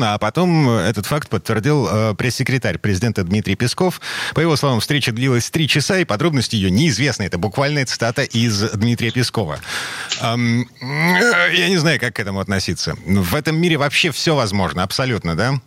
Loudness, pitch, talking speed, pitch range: -17 LUFS, 120 Hz, 165 wpm, 110-145 Hz